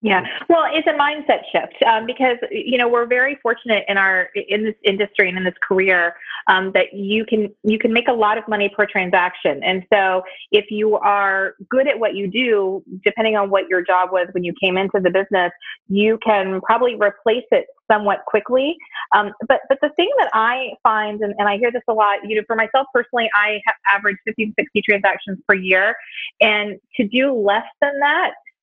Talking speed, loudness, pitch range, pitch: 210 wpm, -18 LUFS, 195-240 Hz, 210 Hz